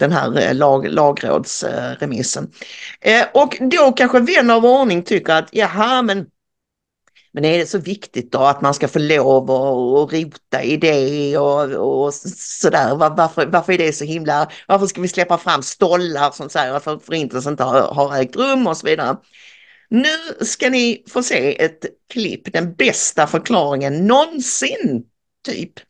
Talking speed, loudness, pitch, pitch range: 165 wpm, -16 LUFS, 165 Hz, 145-240 Hz